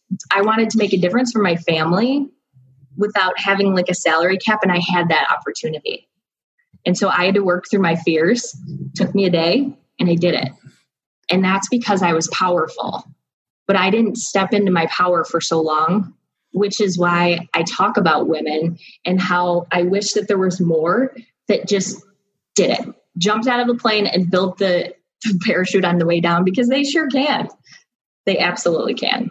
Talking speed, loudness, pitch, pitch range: 190 wpm, -17 LUFS, 185 Hz, 175-215 Hz